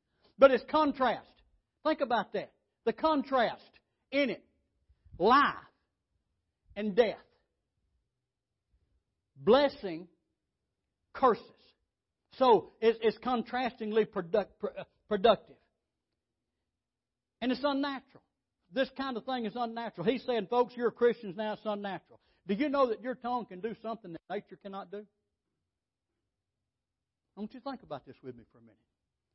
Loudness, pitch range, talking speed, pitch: -31 LUFS, 170-250 Hz, 125 wpm, 220 Hz